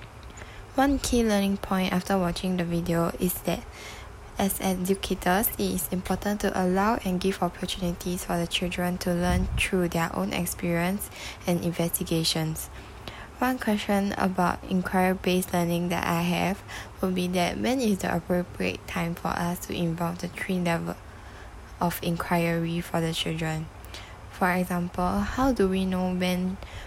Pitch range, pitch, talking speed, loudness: 170-190 Hz, 180 Hz, 150 wpm, -27 LUFS